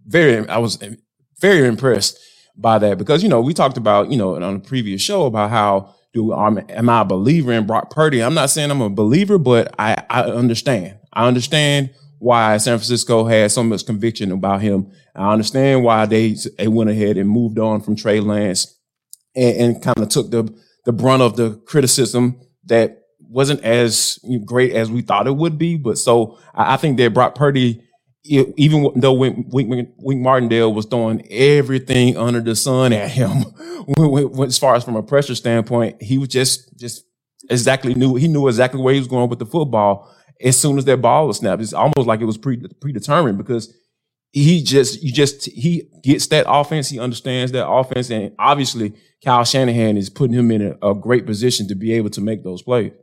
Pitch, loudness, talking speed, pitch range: 120 Hz, -16 LUFS, 205 wpm, 110-135 Hz